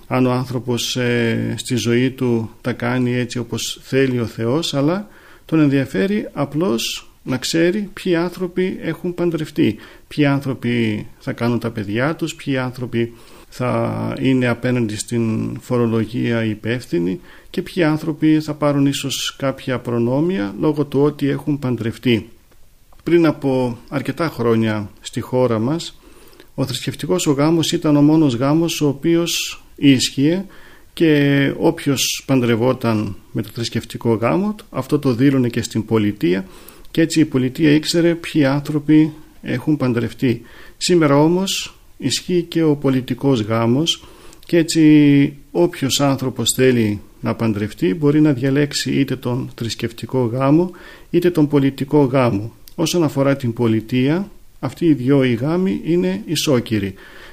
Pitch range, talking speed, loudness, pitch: 120-155 Hz, 135 wpm, -18 LUFS, 135 Hz